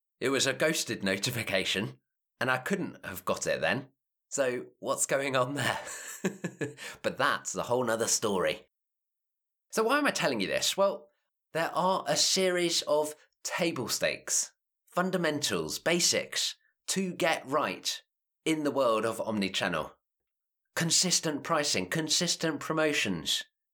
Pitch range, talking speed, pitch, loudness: 135-175 Hz, 130 wpm, 155 Hz, -29 LUFS